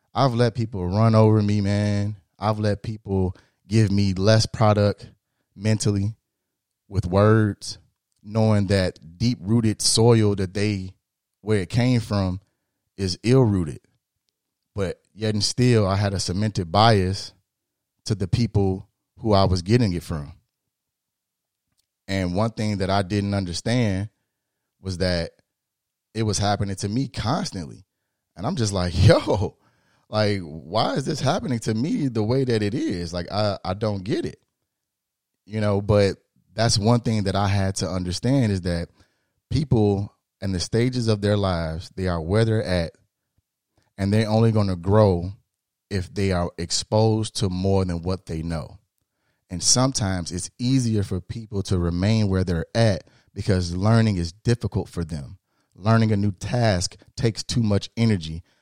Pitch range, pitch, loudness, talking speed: 95-110 Hz, 100 Hz, -23 LUFS, 155 wpm